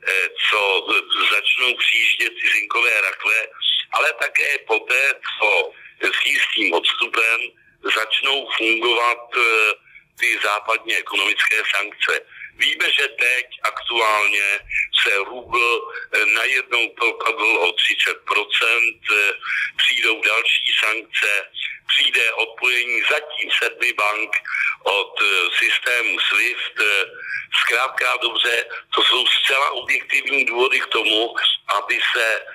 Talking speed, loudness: 95 wpm, -17 LUFS